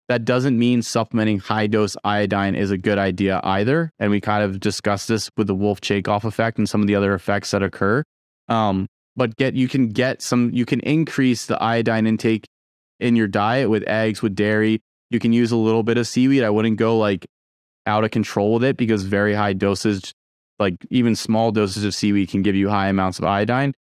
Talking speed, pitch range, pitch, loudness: 215 wpm, 100-115 Hz, 105 Hz, -20 LUFS